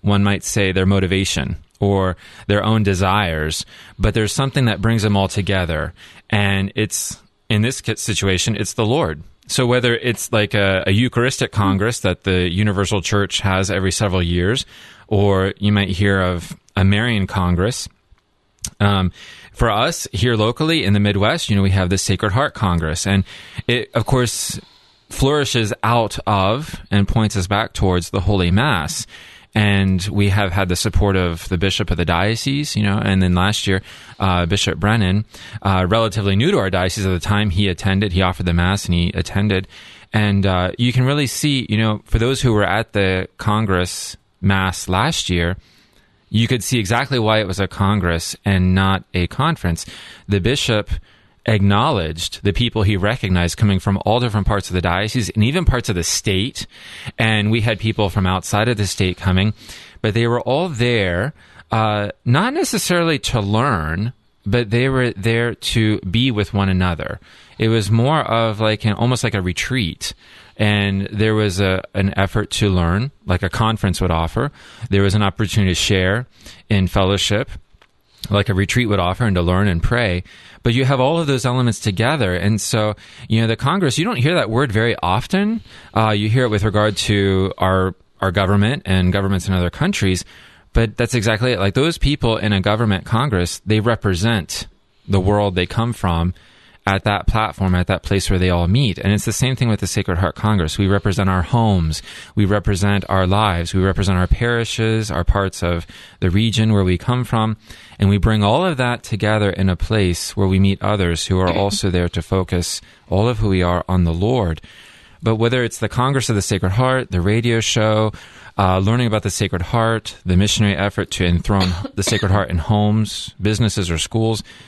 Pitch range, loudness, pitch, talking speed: 95-115 Hz, -18 LUFS, 100 Hz, 190 wpm